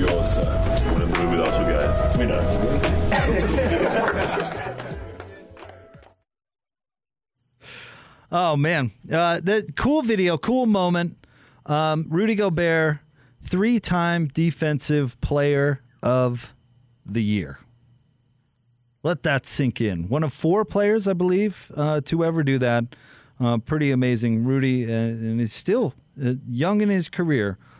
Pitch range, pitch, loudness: 125-170 Hz, 145 Hz, -22 LUFS